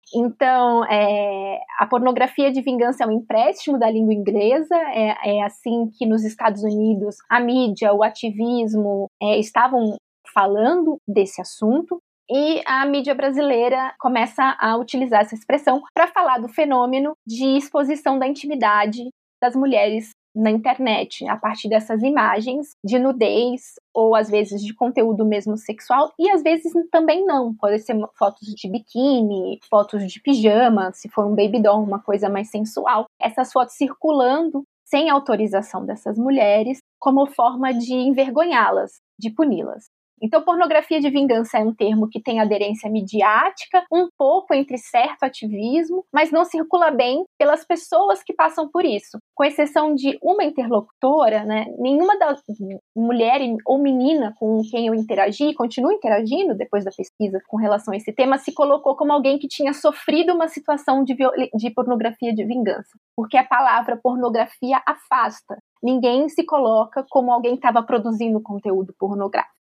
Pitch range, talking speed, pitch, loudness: 215-285 Hz, 150 wpm, 245 Hz, -19 LUFS